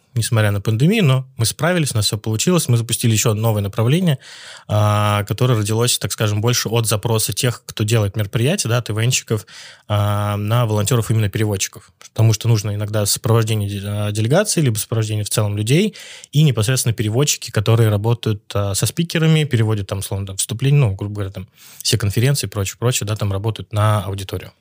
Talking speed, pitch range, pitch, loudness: 180 wpm, 105-125 Hz, 115 Hz, -18 LUFS